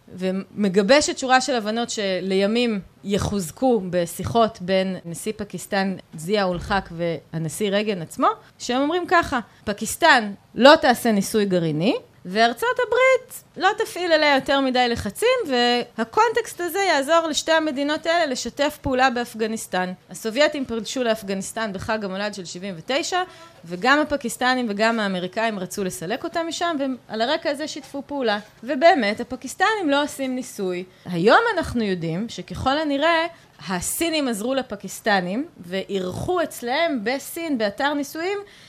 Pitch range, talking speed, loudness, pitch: 200-300 Hz, 120 wpm, -22 LUFS, 240 Hz